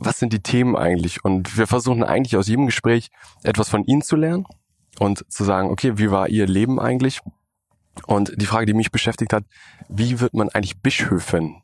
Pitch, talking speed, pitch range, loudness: 110 Hz, 195 wpm, 100-125 Hz, -20 LUFS